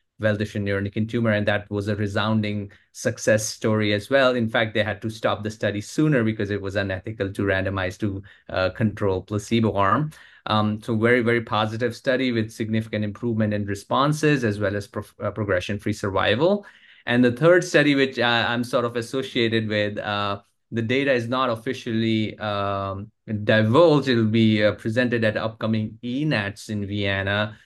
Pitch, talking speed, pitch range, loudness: 110 Hz, 170 wpm, 105-120 Hz, -23 LUFS